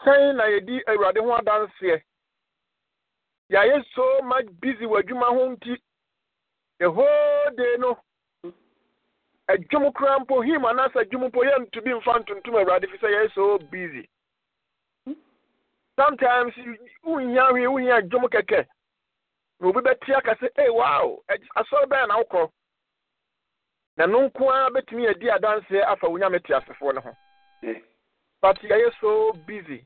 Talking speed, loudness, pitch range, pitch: 105 wpm, -22 LUFS, 210-275 Hz, 245 Hz